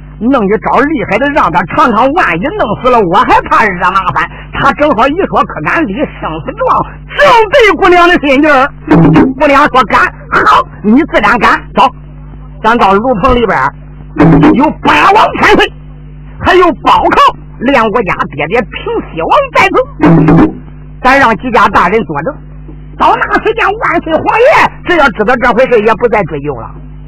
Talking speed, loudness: 235 characters per minute, -8 LUFS